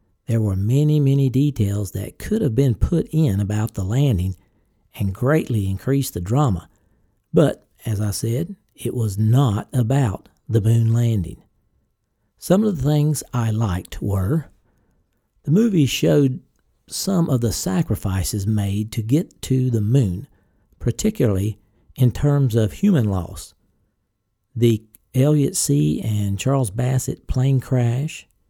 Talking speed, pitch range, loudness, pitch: 135 wpm, 105-140 Hz, -20 LUFS, 115 Hz